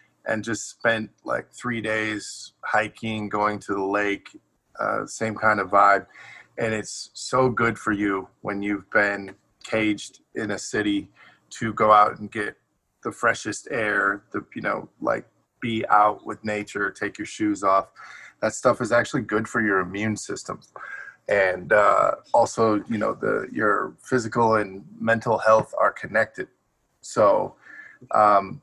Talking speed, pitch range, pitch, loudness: 155 wpm, 105-110 Hz, 105 Hz, -23 LUFS